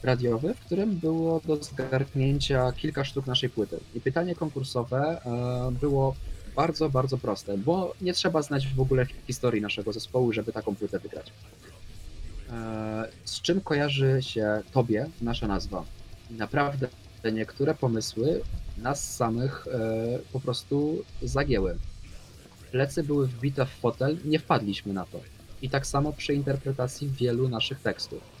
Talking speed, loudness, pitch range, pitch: 135 wpm, -28 LUFS, 110-140 Hz, 125 Hz